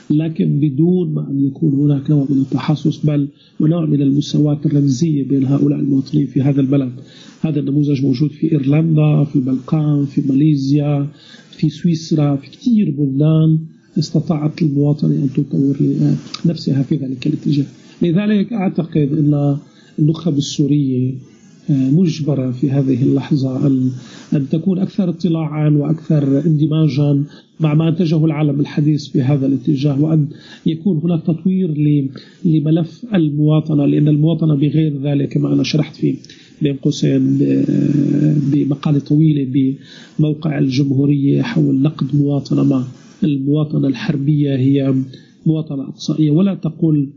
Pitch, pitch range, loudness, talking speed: 150 Hz, 140-160 Hz, -16 LUFS, 120 wpm